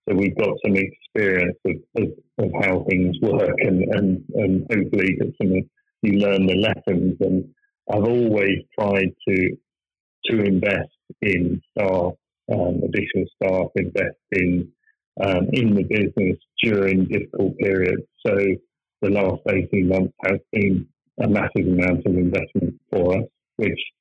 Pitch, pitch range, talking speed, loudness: 95 Hz, 95-105 Hz, 145 wpm, -21 LUFS